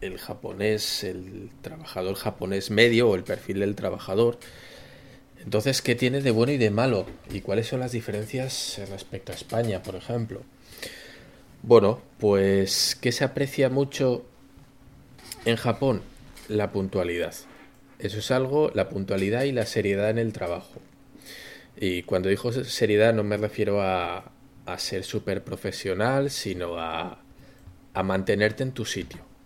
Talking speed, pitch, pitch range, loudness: 140 wpm, 110 Hz, 95-130 Hz, -26 LUFS